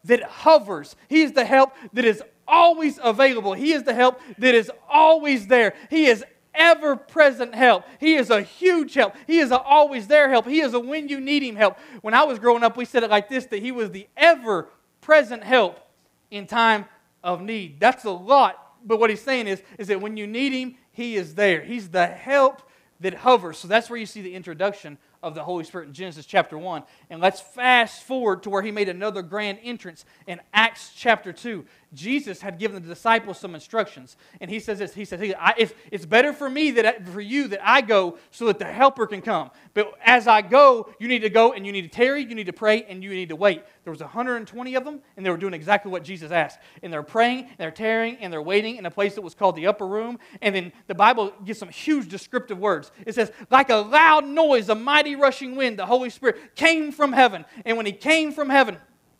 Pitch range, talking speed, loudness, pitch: 195-260 Hz, 230 wpm, -20 LUFS, 225 Hz